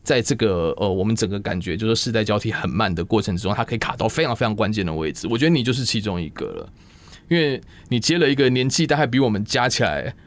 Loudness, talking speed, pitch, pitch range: -21 LUFS, 385 characters per minute, 110 Hz, 100-130 Hz